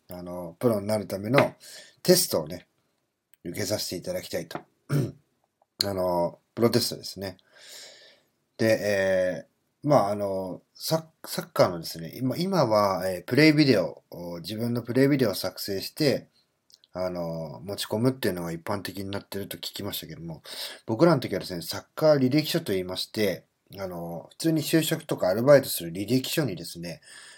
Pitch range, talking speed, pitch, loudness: 90-130 Hz, 340 characters per minute, 100 Hz, -26 LUFS